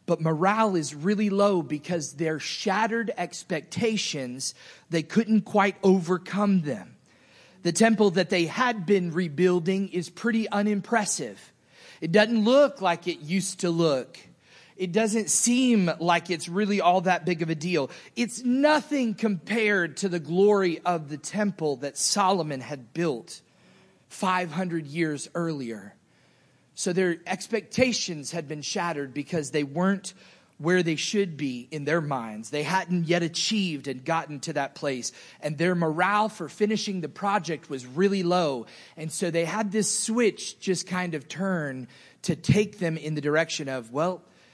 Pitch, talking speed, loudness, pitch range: 180 Hz, 150 wpm, -26 LUFS, 160-205 Hz